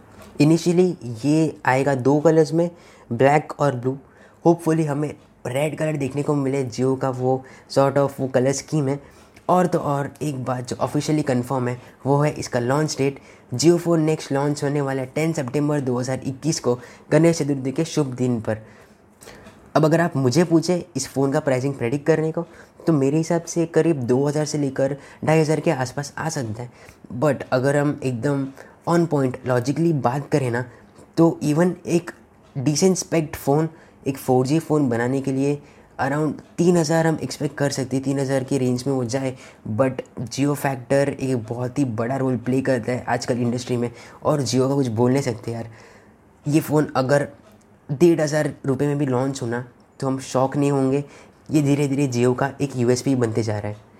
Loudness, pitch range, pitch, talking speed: -22 LUFS, 125-150 Hz, 140 Hz, 185 wpm